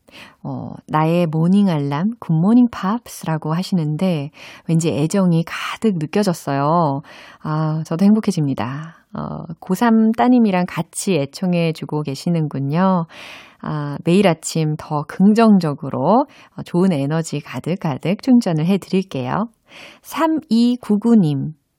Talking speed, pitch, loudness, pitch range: 235 characters per minute, 170 Hz, -18 LUFS, 150-200 Hz